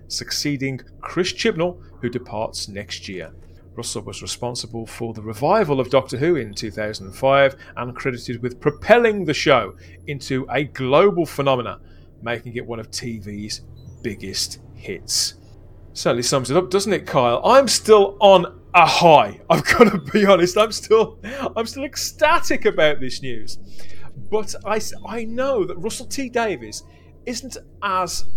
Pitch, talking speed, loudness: 125 Hz, 145 wpm, -19 LUFS